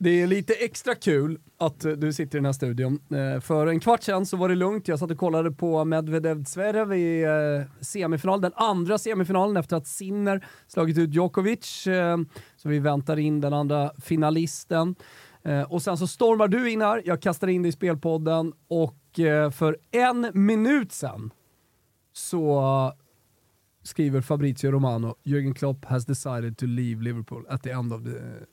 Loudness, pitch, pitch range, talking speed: -25 LUFS, 160 Hz, 135-185 Hz, 165 wpm